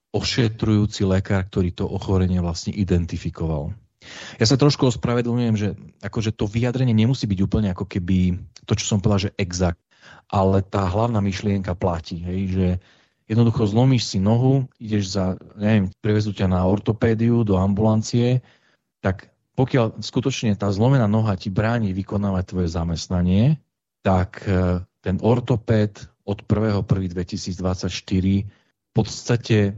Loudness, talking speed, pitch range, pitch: -22 LUFS, 130 wpm, 95-115 Hz, 105 Hz